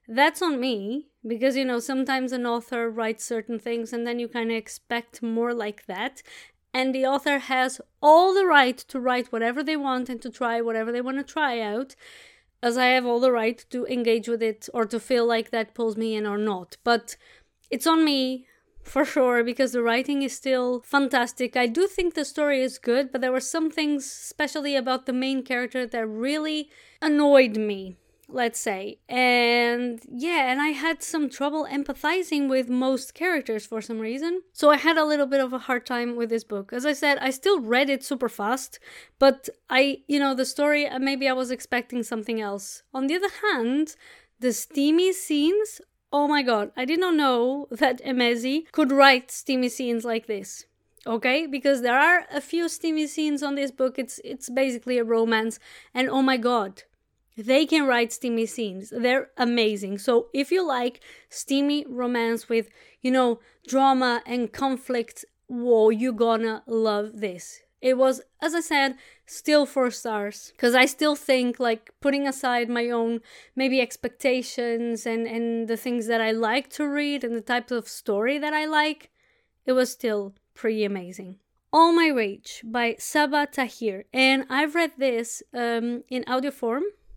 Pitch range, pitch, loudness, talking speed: 235-280 Hz, 255 Hz, -24 LUFS, 185 wpm